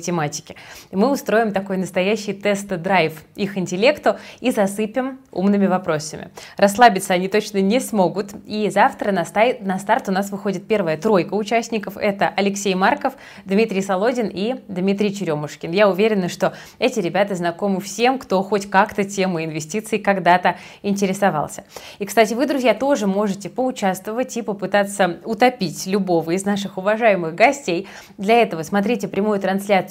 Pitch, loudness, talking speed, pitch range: 200 Hz, -19 LUFS, 140 wpm, 185-220 Hz